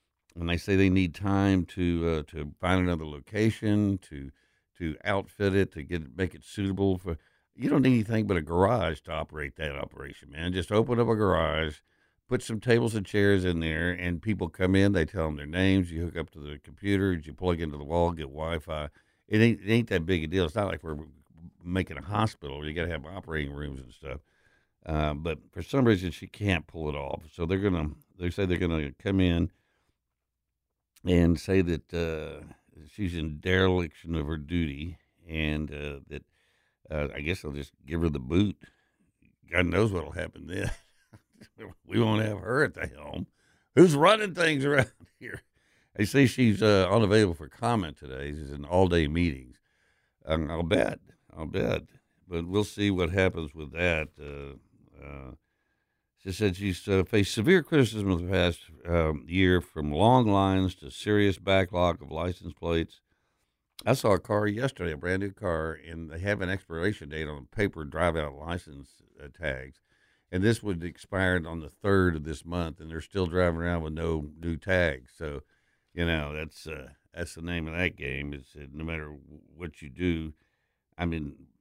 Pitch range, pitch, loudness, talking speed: 75-95 Hz, 85 Hz, -28 LUFS, 190 wpm